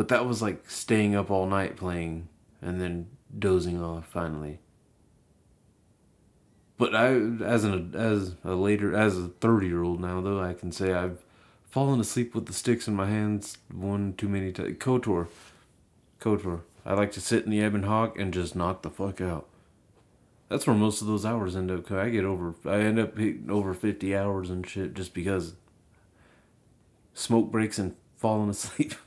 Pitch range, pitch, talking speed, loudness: 90-110 Hz, 100 Hz, 180 wpm, -28 LUFS